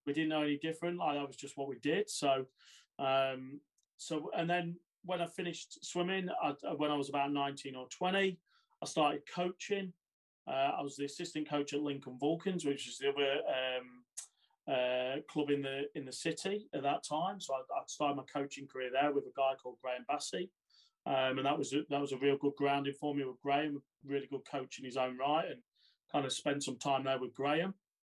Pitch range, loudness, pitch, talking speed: 135-165 Hz, -37 LUFS, 140 Hz, 215 wpm